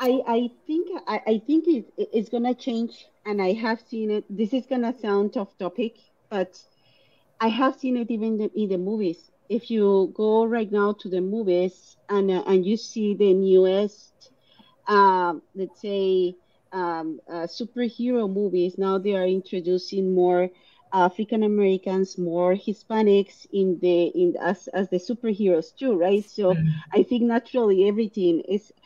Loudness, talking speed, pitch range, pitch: -24 LUFS, 170 wpm, 185-225 Hz, 200 Hz